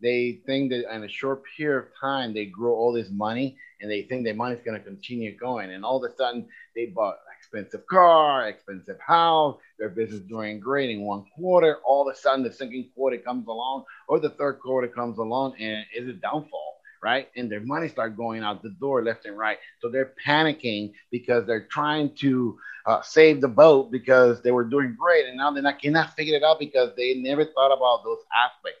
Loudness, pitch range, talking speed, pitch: -24 LUFS, 115-140 Hz, 210 wpm, 125 Hz